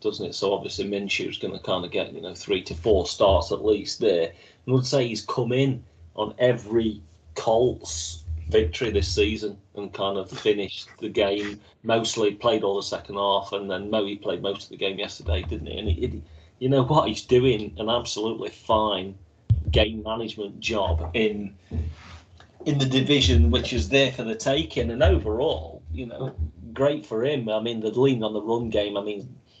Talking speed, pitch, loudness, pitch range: 195 wpm, 105 Hz, -25 LUFS, 95-120 Hz